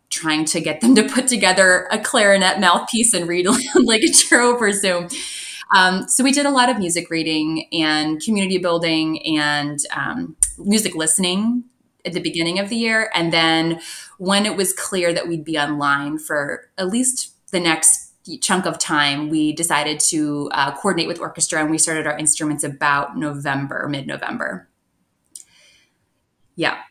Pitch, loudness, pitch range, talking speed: 170 Hz, -17 LUFS, 155-205 Hz, 165 wpm